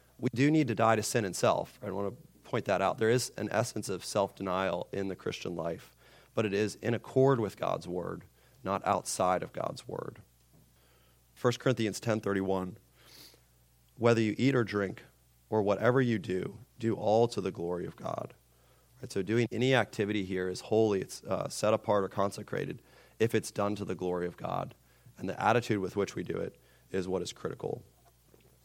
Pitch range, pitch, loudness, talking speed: 90-115 Hz, 105 Hz, -32 LUFS, 195 wpm